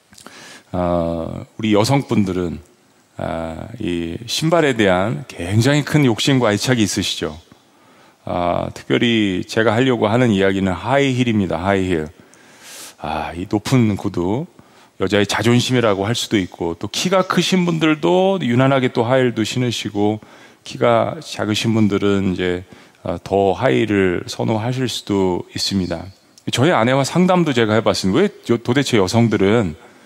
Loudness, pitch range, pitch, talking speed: -18 LUFS, 95-125 Hz, 110 Hz, 280 characters per minute